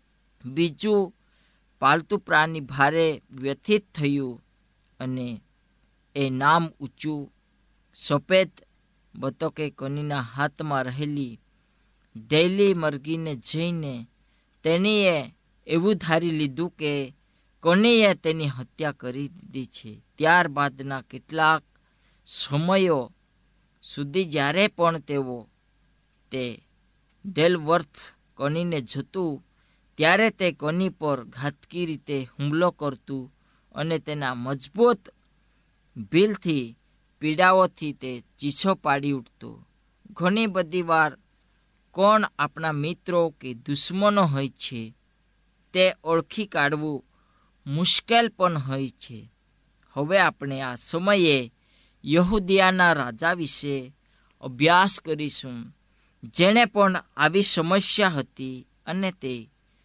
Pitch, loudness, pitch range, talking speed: 150 Hz, -23 LUFS, 135-180 Hz, 90 wpm